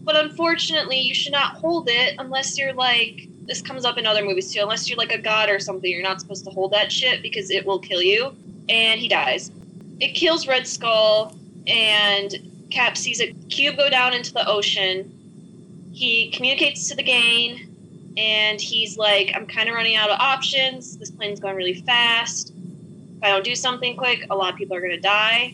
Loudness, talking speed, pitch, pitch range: -19 LUFS, 205 wpm, 210 Hz, 190-240 Hz